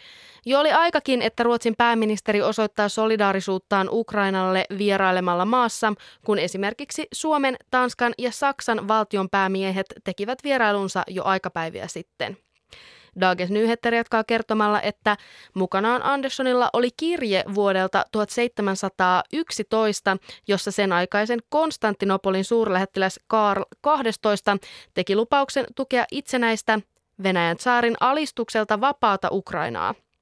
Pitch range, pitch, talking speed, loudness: 195-240 Hz, 215 Hz, 100 wpm, -23 LUFS